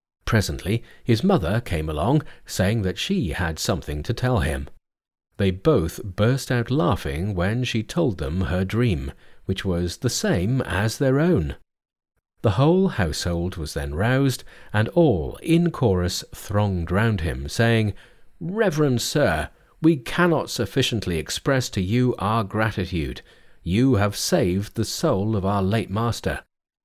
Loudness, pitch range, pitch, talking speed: -23 LUFS, 90-125 Hz, 105 Hz, 145 wpm